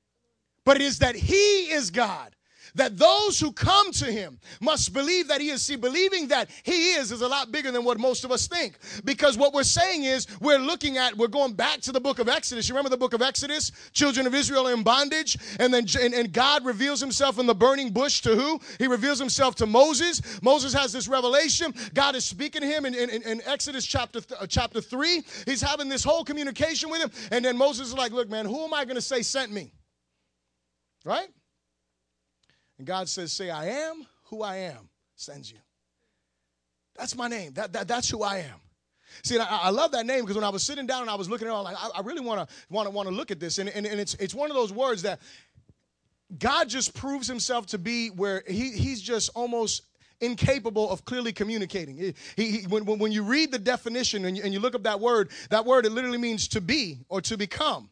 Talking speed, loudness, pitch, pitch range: 230 wpm, -25 LUFS, 245 Hz, 210-275 Hz